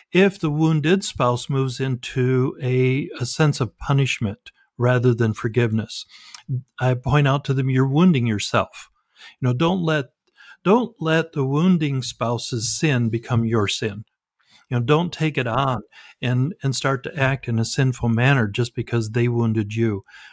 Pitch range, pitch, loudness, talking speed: 120-150 Hz, 130 Hz, -21 LUFS, 160 wpm